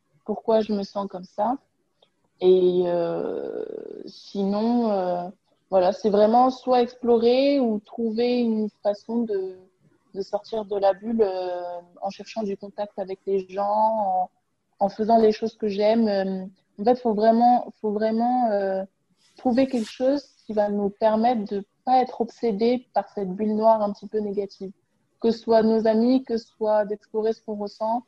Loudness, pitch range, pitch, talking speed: -23 LUFS, 195-230 Hz, 215 Hz, 175 wpm